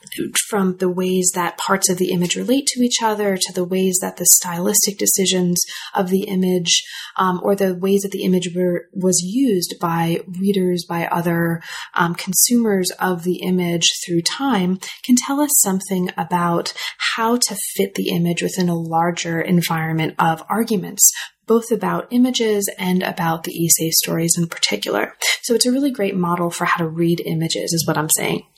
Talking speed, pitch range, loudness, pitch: 175 wpm, 170-200 Hz, -18 LUFS, 185 Hz